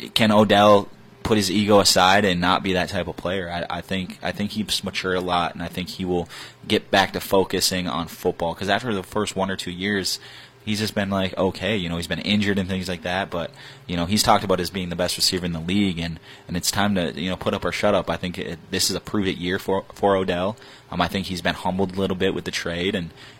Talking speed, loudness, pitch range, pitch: 270 wpm, -22 LUFS, 90-100 Hz, 95 Hz